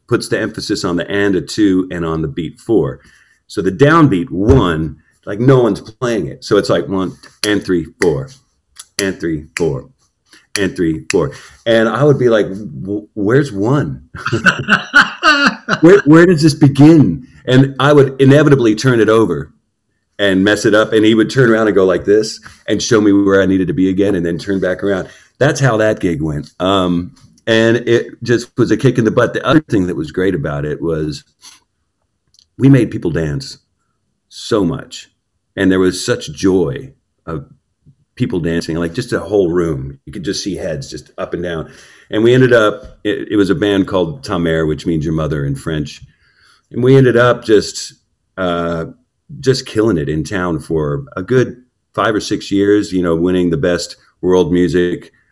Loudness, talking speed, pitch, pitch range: -14 LUFS, 190 wpm, 100 Hz, 85-120 Hz